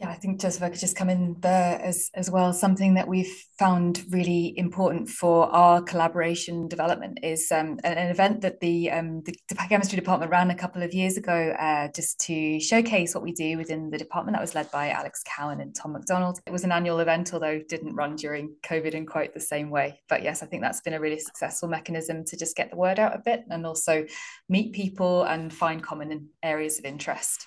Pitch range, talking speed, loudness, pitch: 160-185 Hz, 225 wpm, -26 LUFS, 170 Hz